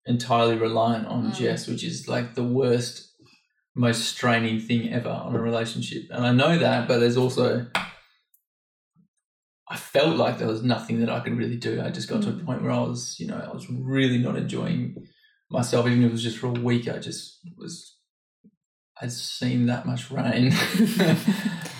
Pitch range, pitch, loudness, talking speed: 115-135 Hz, 120 Hz, -24 LUFS, 185 wpm